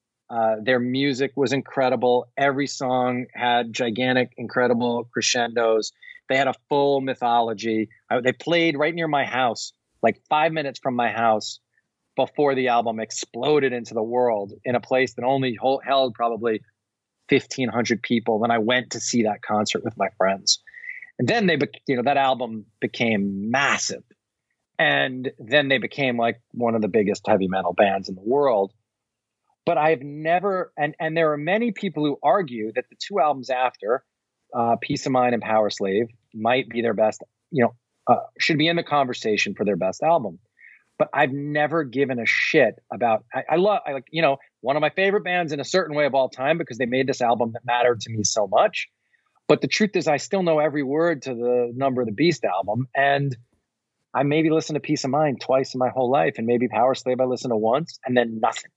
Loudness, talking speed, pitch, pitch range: -22 LUFS, 200 wpm, 125 Hz, 115-145 Hz